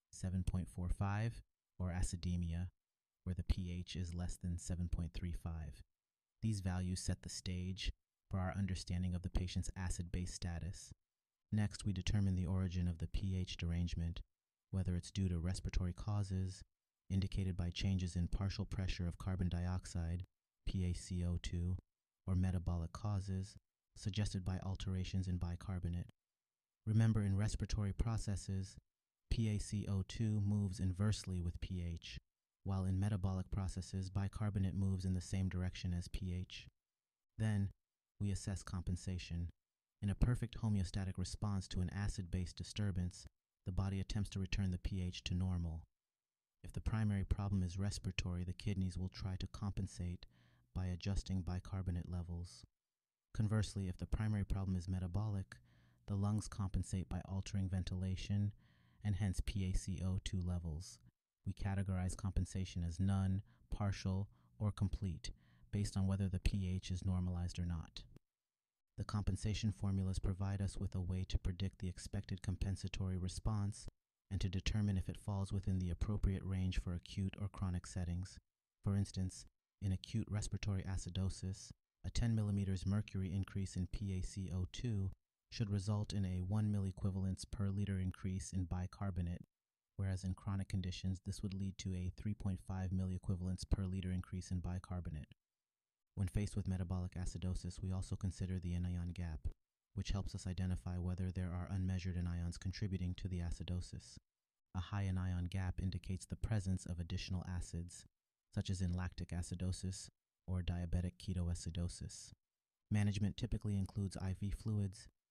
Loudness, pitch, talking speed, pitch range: -42 LUFS, 95 Hz, 140 wpm, 90-100 Hz